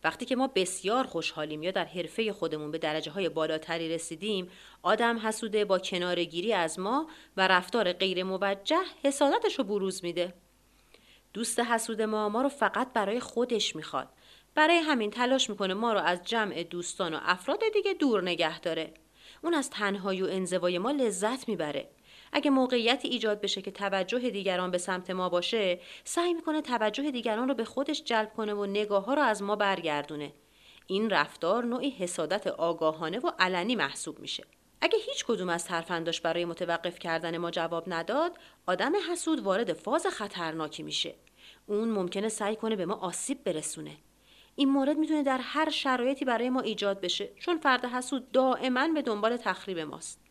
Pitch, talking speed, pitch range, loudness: 210 Hz, 165 wpm, 180-255 Hz, -30 LUFS